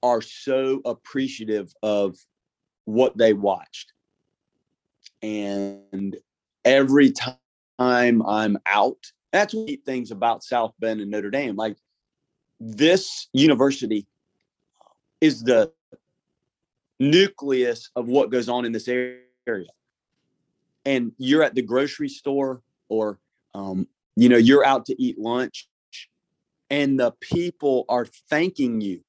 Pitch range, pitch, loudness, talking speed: 110-140 Hz, 125 Hz, -22 LUFS, 115 wpm